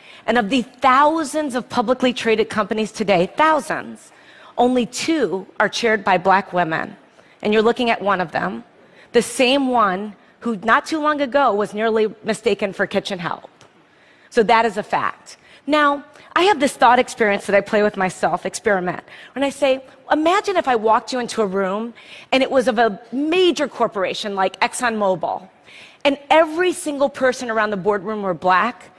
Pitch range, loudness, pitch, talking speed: 205-270 Hz, -19 LUFS, 230 Hz, 175 wpm